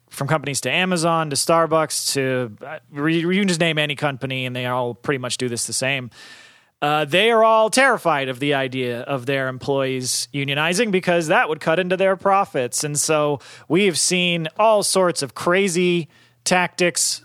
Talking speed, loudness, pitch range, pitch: 175 wpm, -19 LUFS, 130-175 Hz, 150 Hz